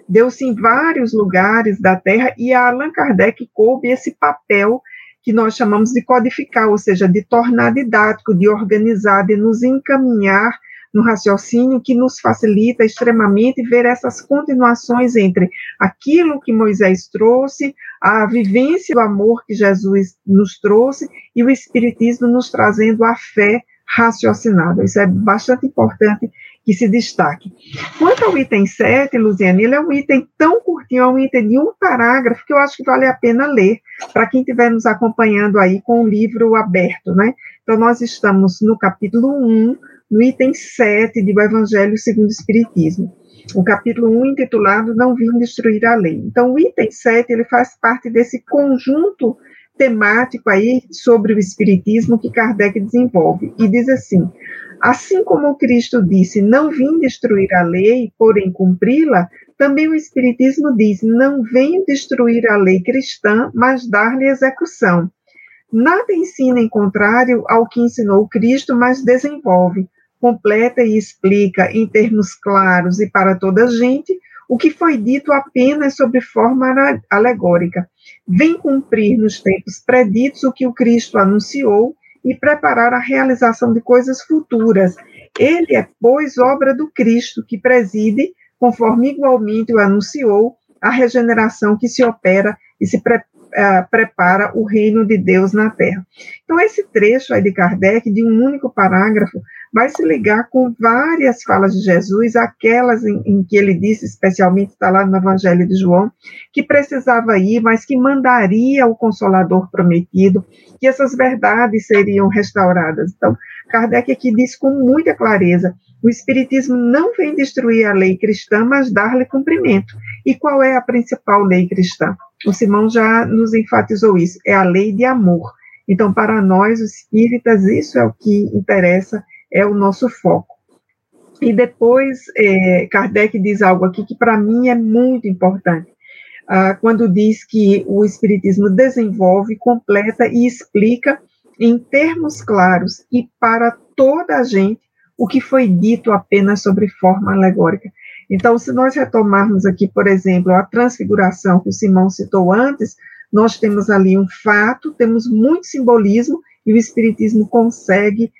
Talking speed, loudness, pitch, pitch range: 155 wpm, -13 LUFS, 230 Hz, 205-255 Hz